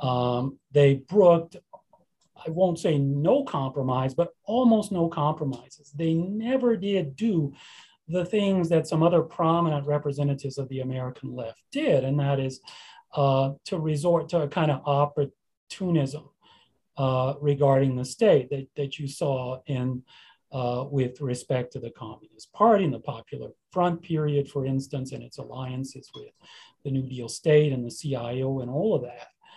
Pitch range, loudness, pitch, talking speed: 135-170 Hz, -26 LUFS, 145 Hz, 155 wpm